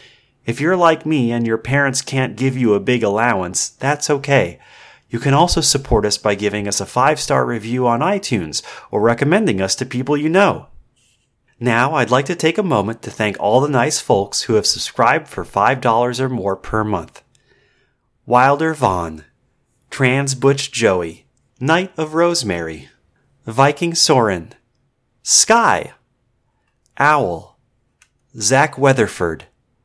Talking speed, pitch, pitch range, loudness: 145 wpm, 125 Hz, 115-140 Hz, -16 LUFS